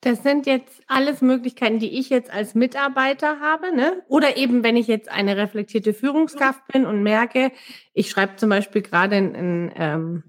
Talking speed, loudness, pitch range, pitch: 180 wpm, -20 LUFS, 205-270 Hz, 245 Hz